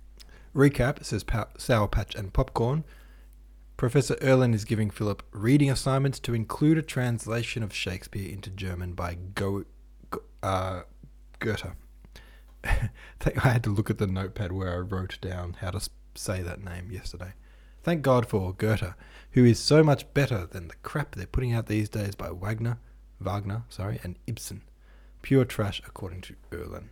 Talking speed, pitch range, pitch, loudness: 160 wpm, 90-120 Hz, 105 Hz, -28 LUFS